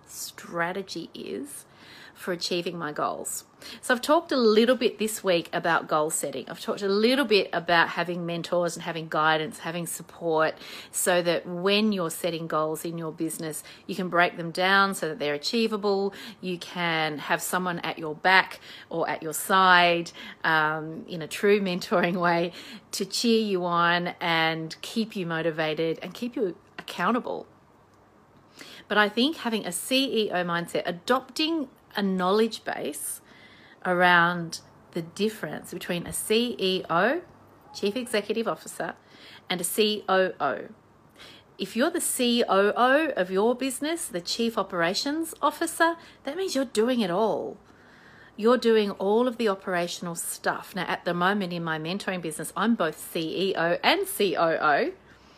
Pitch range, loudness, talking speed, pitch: 170-220 Hz, -26 LUFS, 150 wpm, 185 Hz